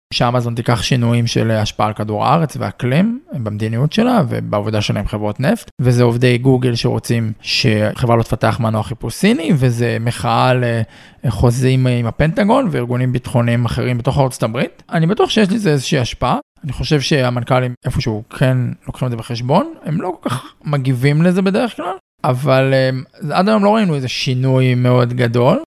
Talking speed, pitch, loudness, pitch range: 165 wpm, 125 Hz, -16 LUFS, 120-150 Hz